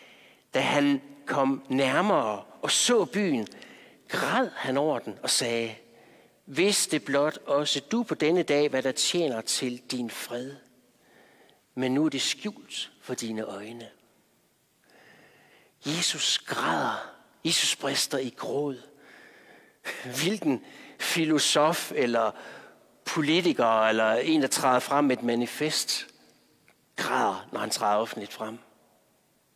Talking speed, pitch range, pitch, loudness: 120 wpm, 125-150 Hz, 135 Hz, -27 LUFS